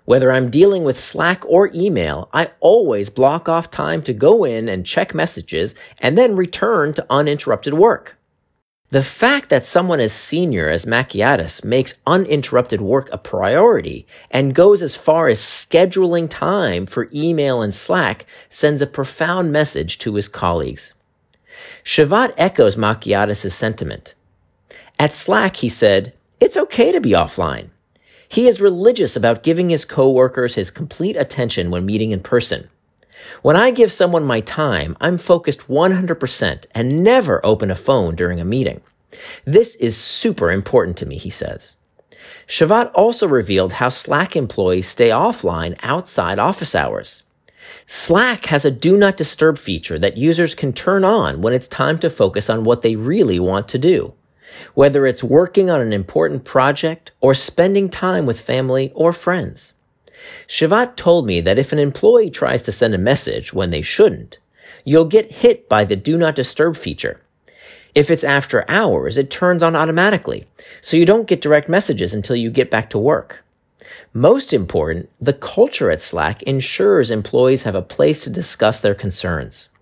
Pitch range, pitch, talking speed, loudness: 120-180 Hz, 150 Hz, 160 wpm, -16 LUFS